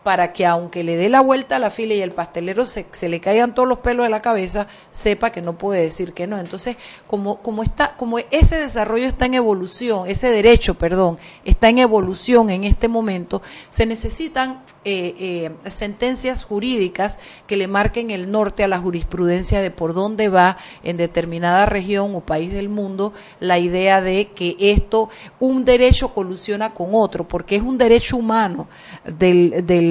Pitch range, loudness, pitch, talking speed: 180-230 Hz, -18 LUFS, 200 Hz, 185 wpm